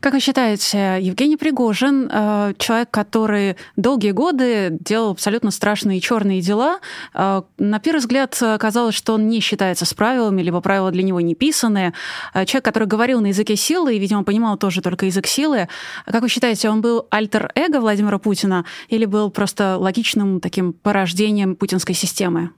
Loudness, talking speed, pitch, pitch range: -18 LUFS, 155 wpm, 210 Hz, 195-235 Hz